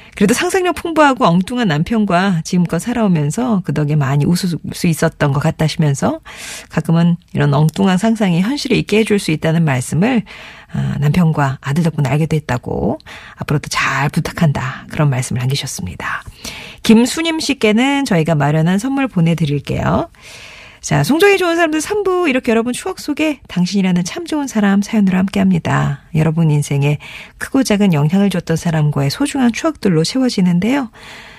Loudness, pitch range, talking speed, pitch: -15 LUFS, 155-235 Hz, 365 characters per minute, 185 Hz